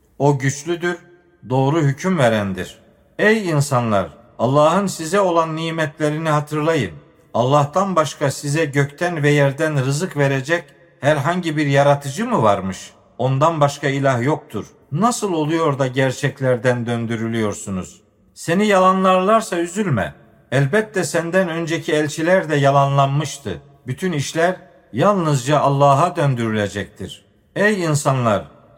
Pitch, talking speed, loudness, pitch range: 145 Hz, 105 wpm, -18 LUFS, 135-170 Hz